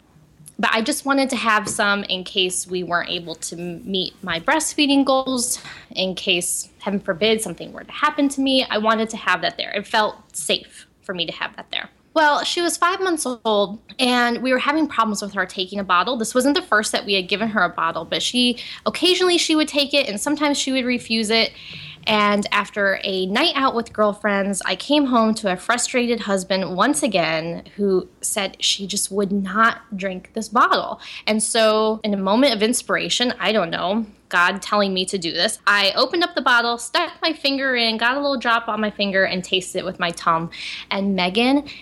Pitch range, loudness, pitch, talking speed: 195-255 Hz, -20 LUFS, 215 Hz, 210 wpm